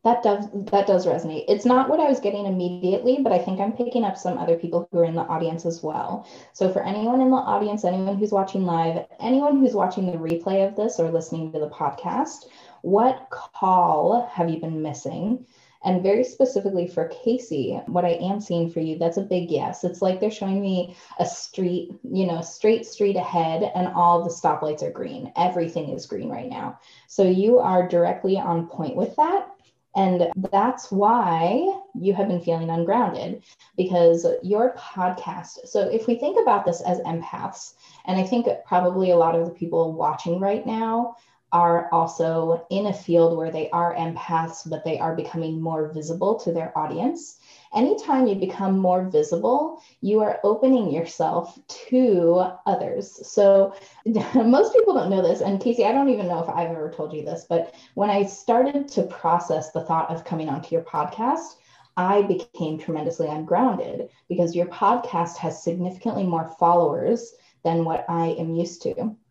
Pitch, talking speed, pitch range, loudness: 185 Hz, 180 wpm, 170-225 Hz, -23 LUFS